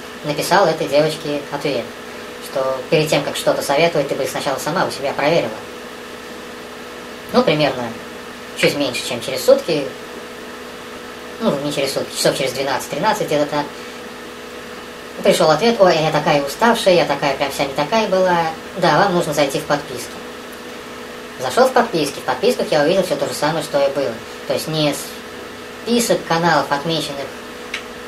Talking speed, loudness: 150 wpm, -18 LUFS